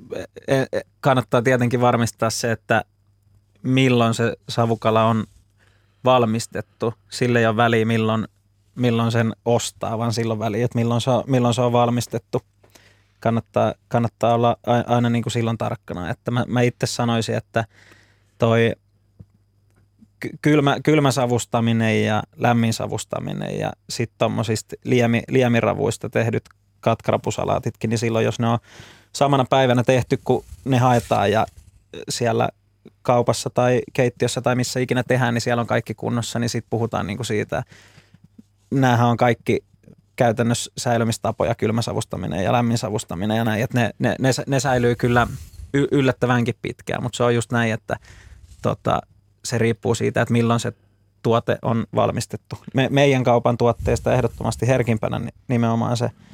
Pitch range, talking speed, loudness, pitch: 110-125 Hz, 140 wpm, -21 LUFS, 115 Hz